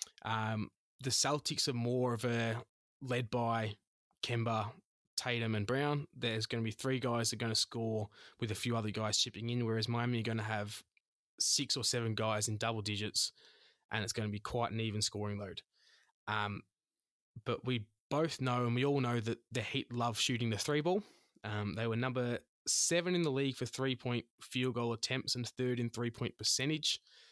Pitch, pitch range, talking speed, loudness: 120 Hz, 110-125 Hz, 200 wpm, -36 LUFS